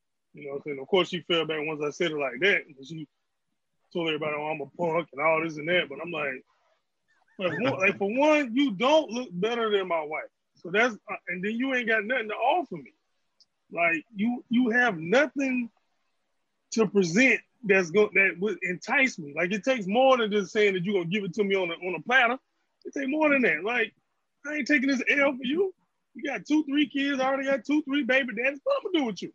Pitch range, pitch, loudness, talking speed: 180-270 Hz, 220 Hz, -26 LUFS, 240 wpm